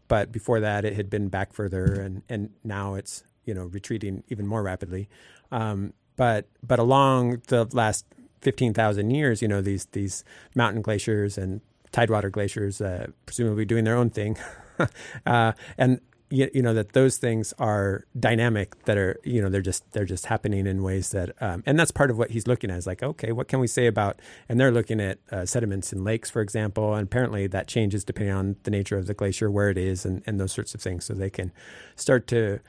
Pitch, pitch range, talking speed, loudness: 105 Hz, 100-120 Hz, 210 wpm, -26 LUFS